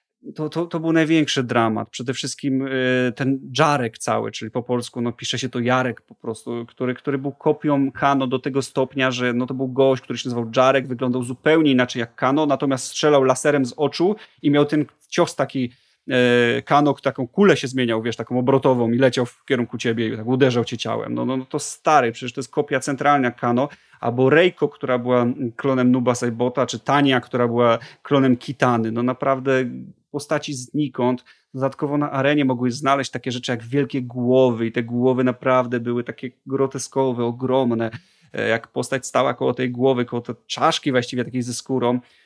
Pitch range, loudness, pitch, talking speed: 125-140 Hz, -21 LUFS, 130 Hz, 185 wpm